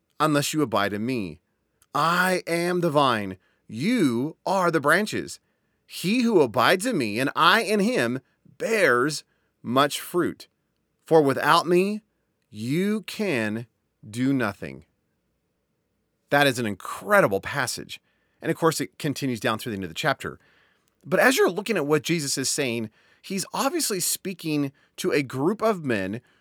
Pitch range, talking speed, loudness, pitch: 120-180 Hz, 150 wpm, -24 LUFS, 150 Hz